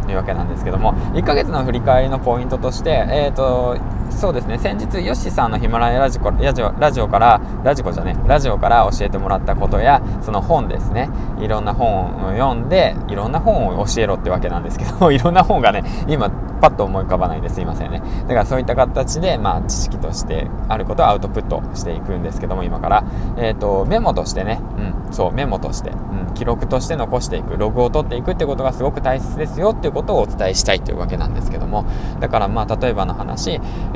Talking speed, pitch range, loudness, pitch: 455 characters per minute, 95-125 Hz, -18 LUFS, 110 Hz